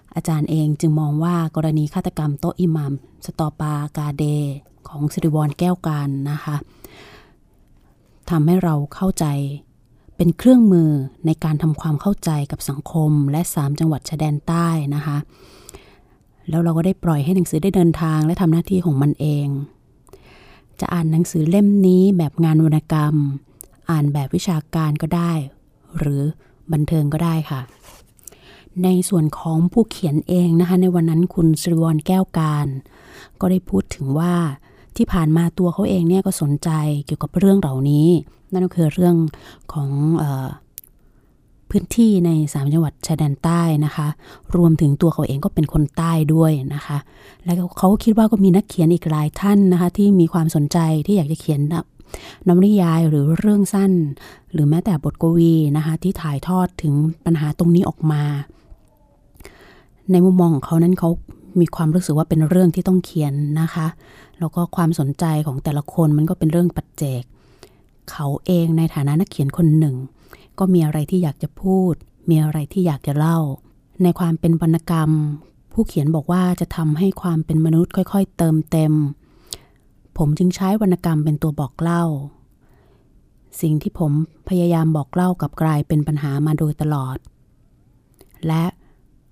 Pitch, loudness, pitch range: 160 Hz, -18 LUFS, 150-175 Hz